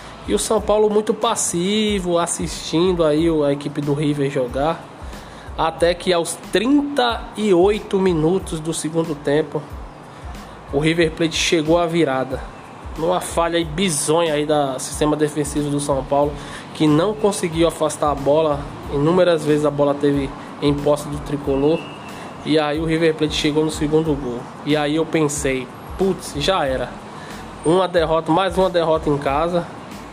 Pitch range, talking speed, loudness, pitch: 145-175 Hz, 150 wpm, -19 LUFS, 155 Hz